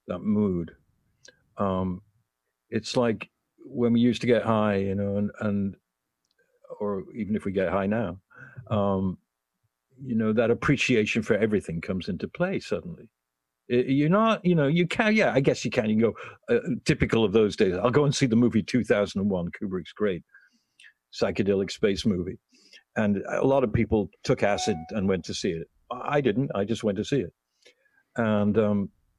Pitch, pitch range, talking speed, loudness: 105 Hz, 95-120 Hz, 180 wpm, -26 LUFS